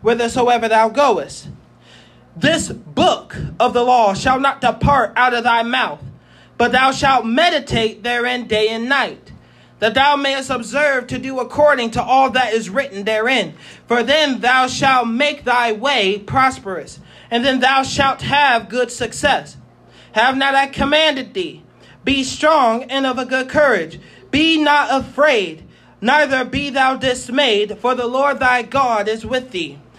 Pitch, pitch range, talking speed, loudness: 255 Hz, 235-275 Hz, 155 wpm, -16 LUFS